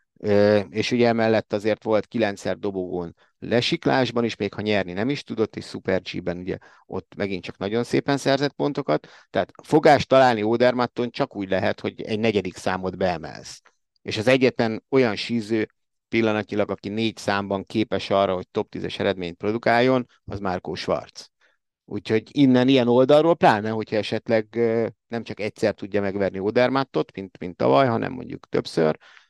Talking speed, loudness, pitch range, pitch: 155 wpm, -23 LUFS, 100-120 Hz, 110 Hz